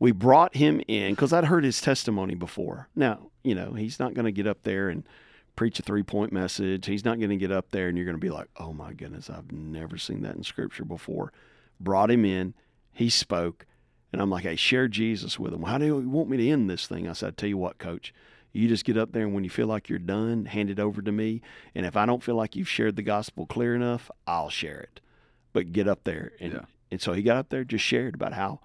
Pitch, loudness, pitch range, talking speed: 105 Hz, -27 LUFS, 95-120 Hz, 260 wpm